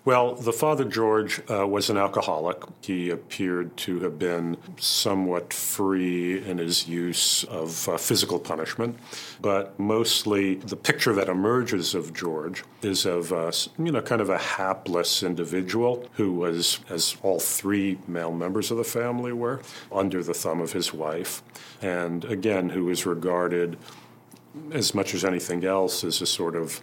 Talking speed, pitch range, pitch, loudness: 160 wpm, 85-110 Hz, 95 Hz, -26 LUFS